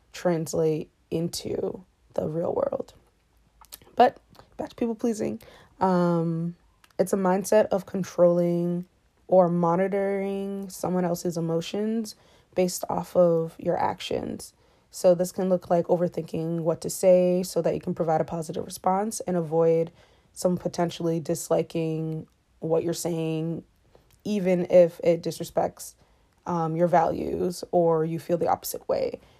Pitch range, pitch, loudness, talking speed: 165-185 Hz, 175 Hz, -26 LUFS, 130 wpm